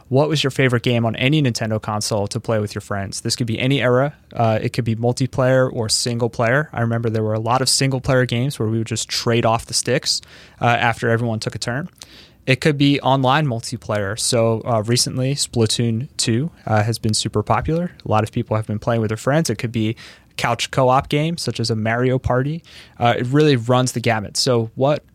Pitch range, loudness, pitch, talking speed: 115-130 Hz, -19 LUFS, 120 Hz, 230 wpm